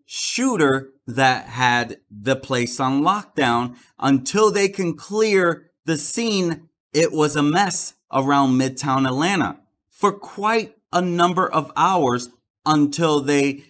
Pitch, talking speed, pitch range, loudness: 145 Hz, 125 wpm, 130-175 Hz, -20 LUFS